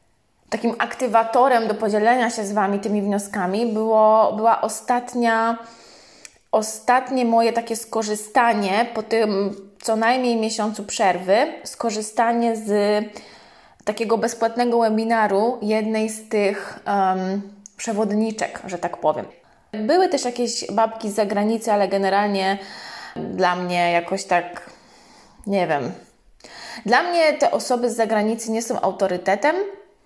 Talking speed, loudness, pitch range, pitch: 115 wpm, -21 LUFS, 205-230 Hz, 220 Hz